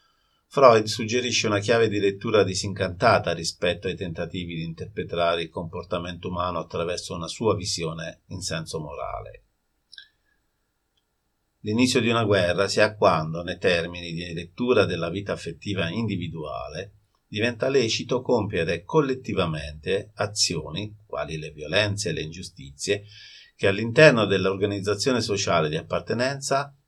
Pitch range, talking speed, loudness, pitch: 85-115 Hz, 120 wpm, -24 LUFS, 100 Hz